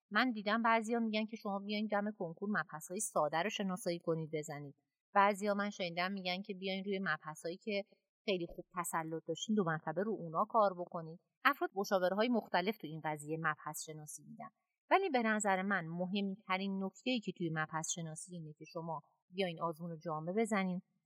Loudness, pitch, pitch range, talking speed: -37 LUFS, 185 Hz, 165-205 Hz, 180 wpm